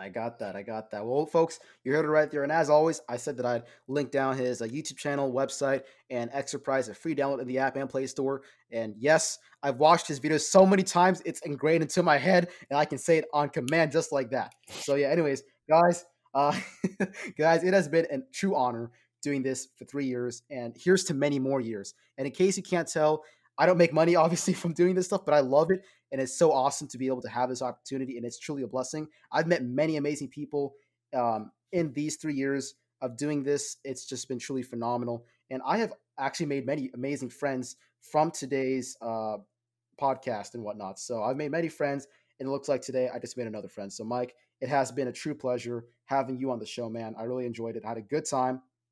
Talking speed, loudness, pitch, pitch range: 235 wpm, -29 LUFS, 135 Hz, 125-155 Hz